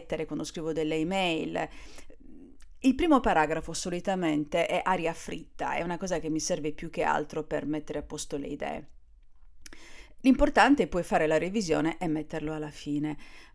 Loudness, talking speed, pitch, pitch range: -29 LUFS, 160 wpm, 160 Hz, 150-185 Hz